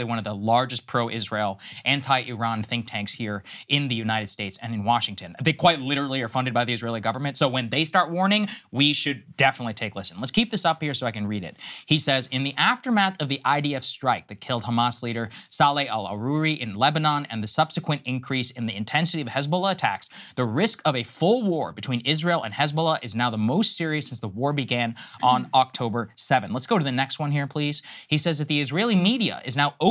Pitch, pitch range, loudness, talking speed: 135 Hz, 115-155 Hz, -24 LUFS, 225 wpm